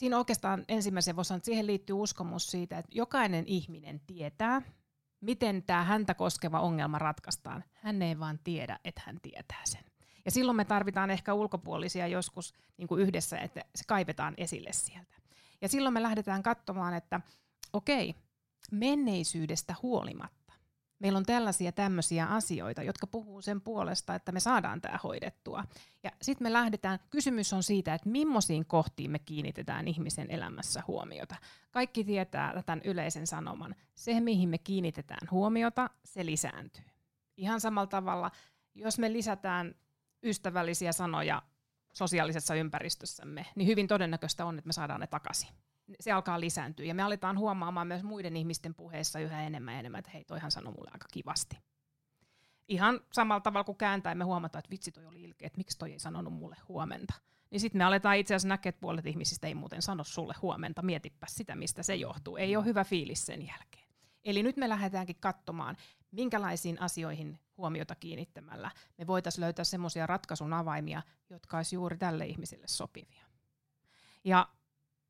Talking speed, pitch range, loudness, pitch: 160 wpm, 160-200 Hz, -34 LUFS, 180 Hz